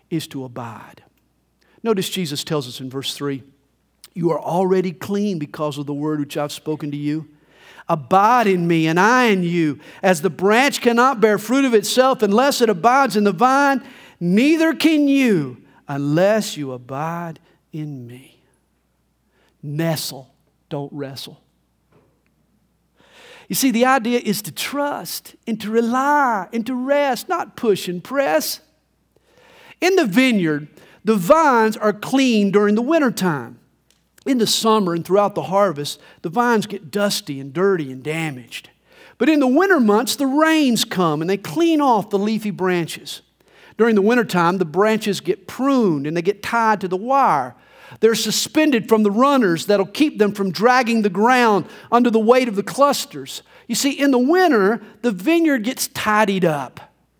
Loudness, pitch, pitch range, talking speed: -18 LUFS, 205 Hz, 160-250 Hz, 160 wpm